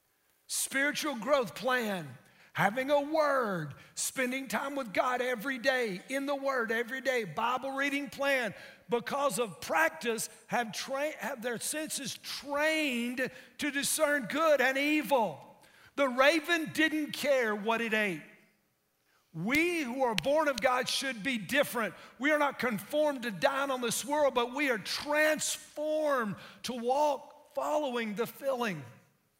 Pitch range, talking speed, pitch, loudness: 235-290 Hz, 140 wpm, 265 Hz, -31 LUFS